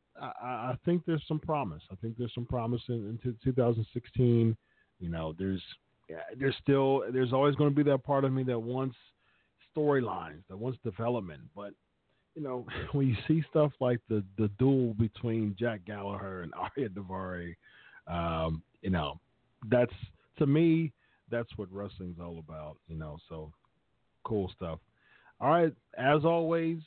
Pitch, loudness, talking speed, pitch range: 120 Hz, -32 LUFS, 160 wpm, 95-135 Hz